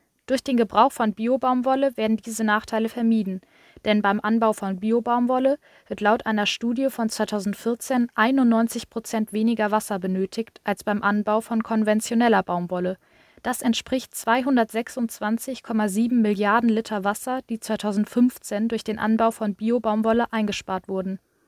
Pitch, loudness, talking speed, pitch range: 225 Hz, -23 LUFS, 130 wpm, 210-235 Hz